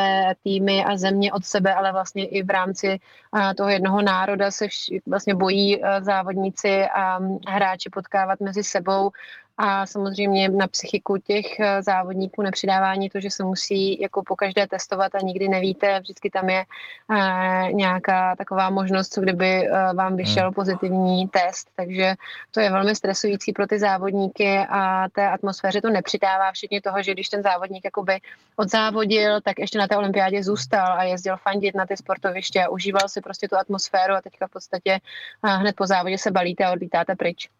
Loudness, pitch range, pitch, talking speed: -22 LUFS, 190-200 Hz, 195 Hz, 165 wpm